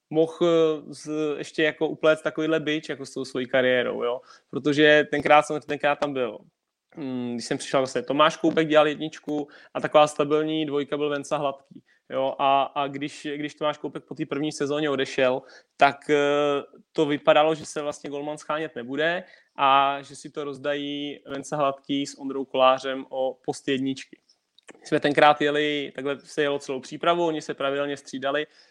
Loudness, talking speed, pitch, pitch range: -24 LUFS, 165 wpm, 145 Hz, 140-155 Hz